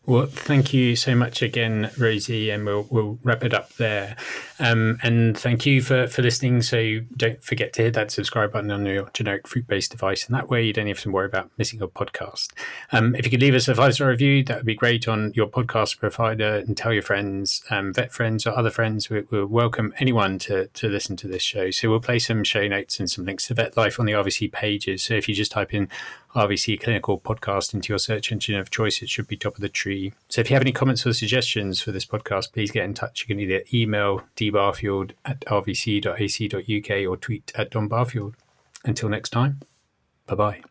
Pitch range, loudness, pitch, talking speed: 100-120 Hz, -23 LUFS, 110 Hz, 230 wpm